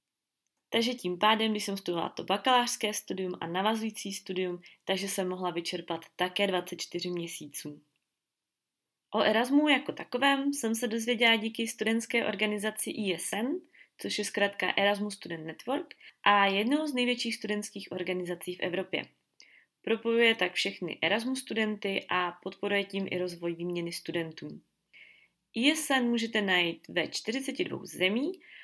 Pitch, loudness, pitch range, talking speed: 205 Hz, -30 LUFS, 180-230 Hz, 130 wpm